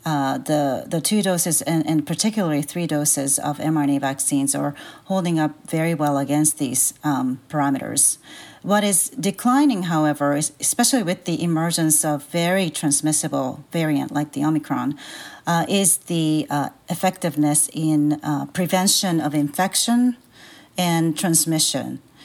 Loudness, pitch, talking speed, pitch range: -20 LUFS, 155 Hz, 135 wpm, 145-175 Hz